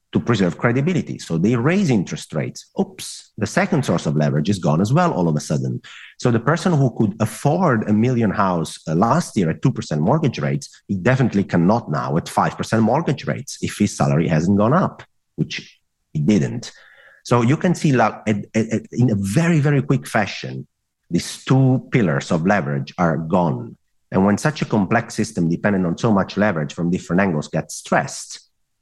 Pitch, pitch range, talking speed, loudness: 110 Hz, 90-130 Hz, 180 wpm, -19 LUFS